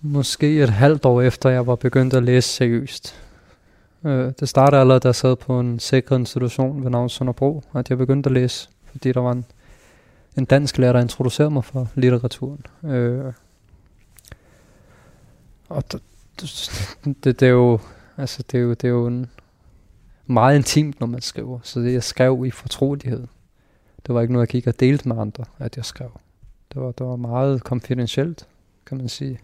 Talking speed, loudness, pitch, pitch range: 185 wpm, -19 LUFS, 125 Hz, 120-130 Hz